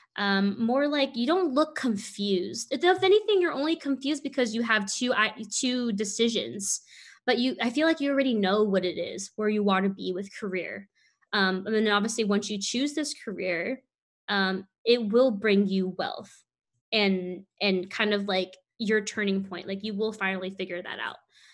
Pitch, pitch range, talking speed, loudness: 215 Hz, 195-255 Hz, 190 wpm, -27 LUFS